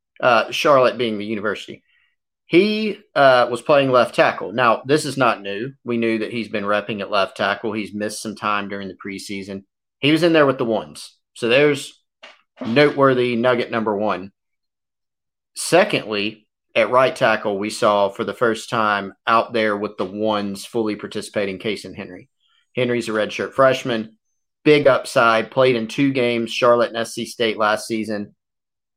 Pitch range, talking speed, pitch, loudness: 105-125 Hz, 170 wpm, 110 Hz, -19 LUFS